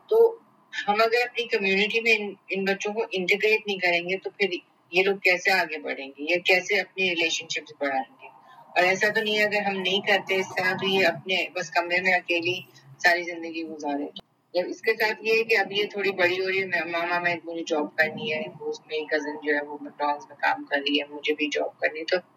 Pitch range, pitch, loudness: 160-200 Hz, 180 Hz, -24 LUFS